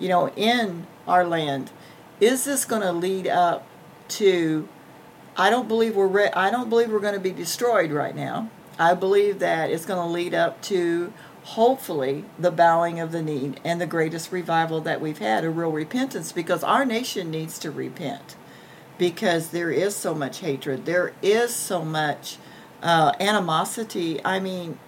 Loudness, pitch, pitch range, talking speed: -23 LUFS, 175 Hz, 165-205 Hz, 170 wpm